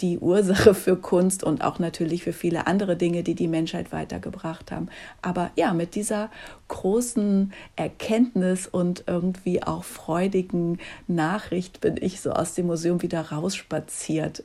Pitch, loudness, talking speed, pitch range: 180 Hz, -25 LUFS, 145 wpm, 170-190 Hz